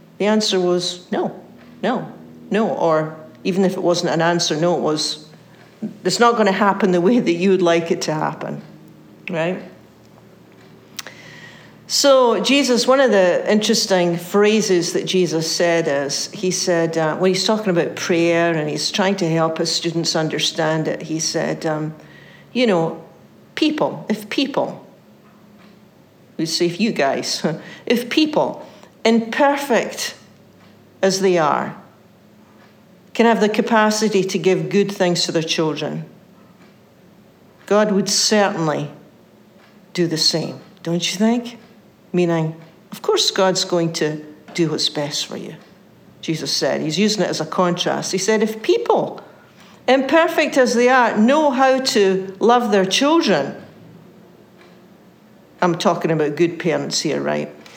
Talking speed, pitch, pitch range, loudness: 145 wpm, 185 Hz, 165-215 Hz, -18 LUFS